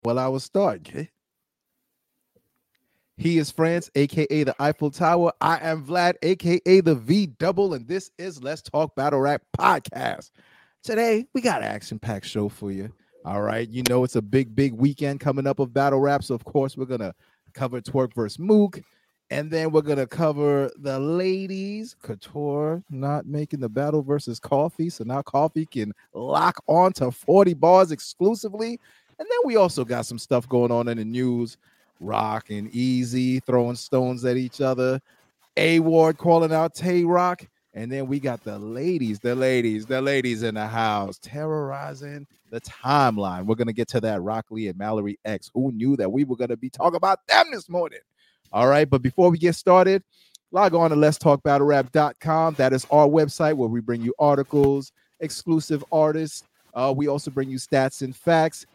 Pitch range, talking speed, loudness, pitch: 125-160 Hz, 185 wpm, -23 LUFS, 140 Hz